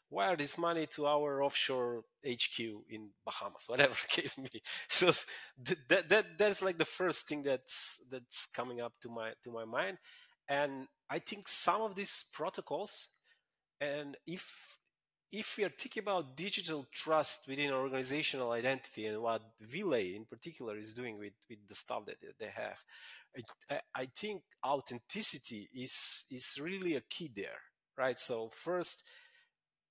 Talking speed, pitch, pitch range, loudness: 155 wpm, 140 Hz, 120-180 Hz, -33 LUFS